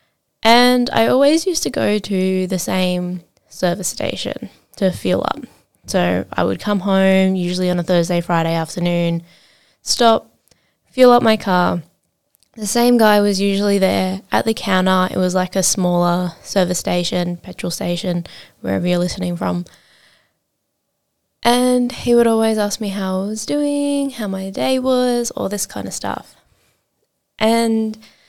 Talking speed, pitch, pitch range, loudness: 155 wpm, 190 Hz, 180-225 Hz, -17 LUFS